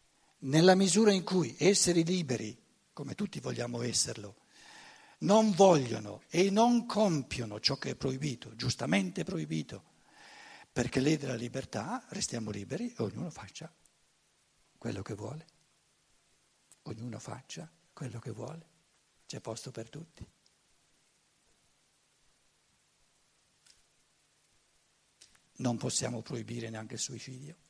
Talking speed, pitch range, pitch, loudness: 105 wpm, 115-175 Hz, 135 Hz, -31 LUFS